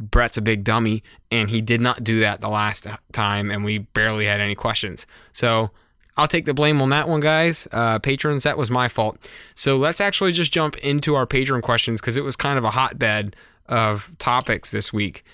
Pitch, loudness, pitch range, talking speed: 115 Hz, -21 LUFS, 110-140 Hz, 210 wpm